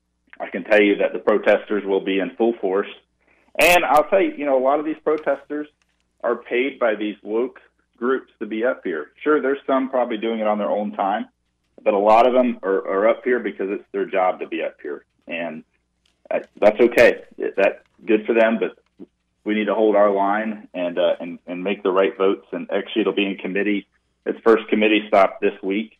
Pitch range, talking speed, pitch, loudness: 95-135 Hz, 215 wpm, 105 Hz, -20 LUFS